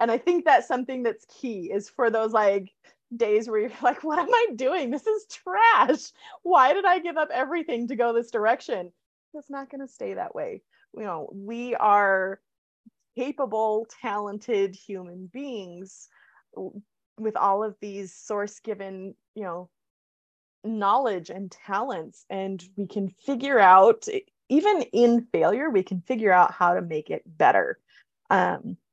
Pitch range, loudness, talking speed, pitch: 195-265 Hz, -24 LUFS, 160 wpm, 220 Hz